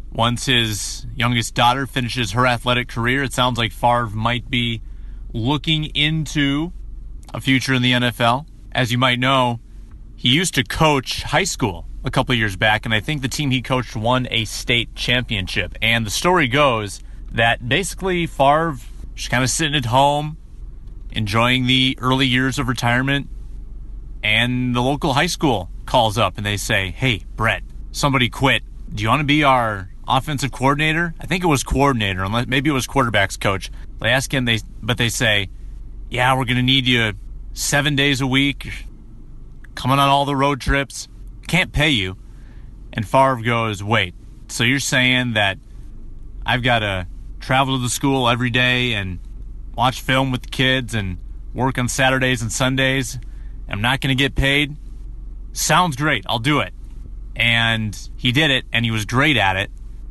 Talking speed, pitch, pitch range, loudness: 175 wpm, 125 Hz, 110-135 Hz, -18 LUFS